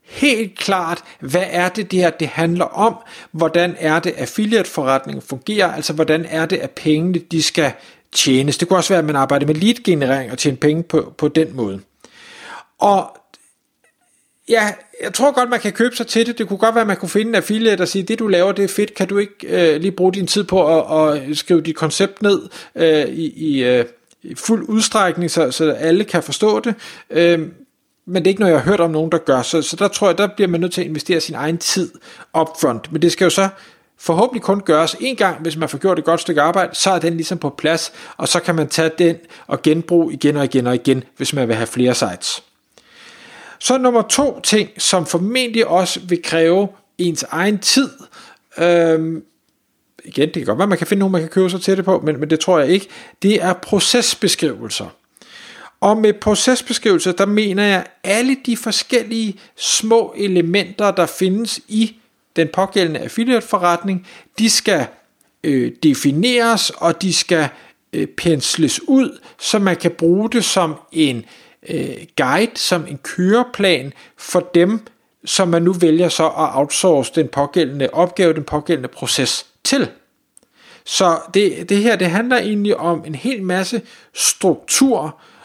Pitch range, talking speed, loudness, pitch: 160-210 Hz, 195 wpm, -16 LUFS, 180 Hz